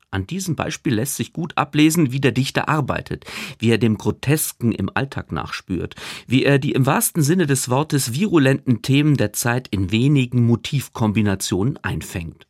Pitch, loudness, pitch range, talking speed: 130 Hz, -20 LUFS, 110-145 Hz, 165 wpm